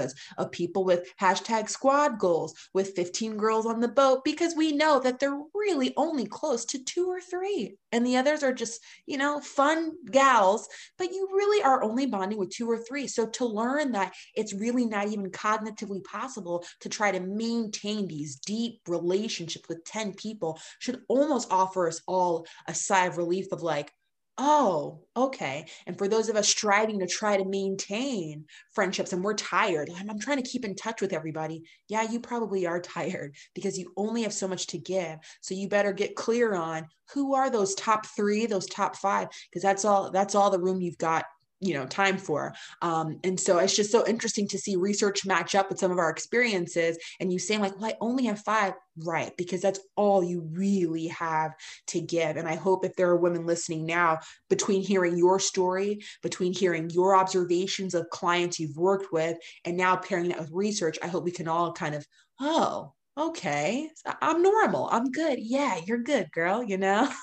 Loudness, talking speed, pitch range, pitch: -28 LUFS, 195 wpm, 175-230 Hz, 195 Hz